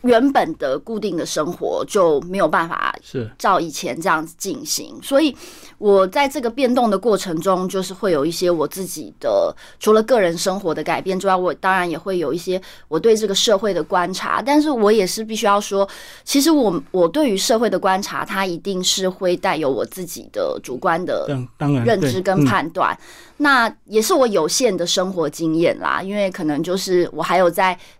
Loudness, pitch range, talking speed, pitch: -19 LUFS, 180-245 Hz, 285 characters per minute, 195 Hz